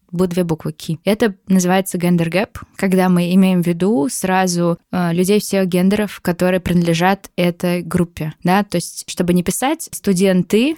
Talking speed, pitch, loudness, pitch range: 155 wpm, 185 Hz, -17 LUFS, 175-195 Hz